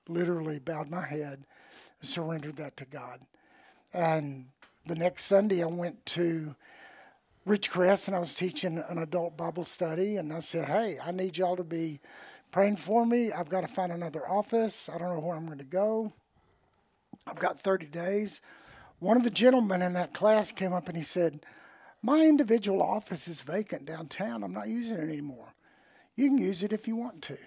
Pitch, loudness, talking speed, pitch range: 180 Hz, -30 LUFS, 190 wpm, 165-200 Hz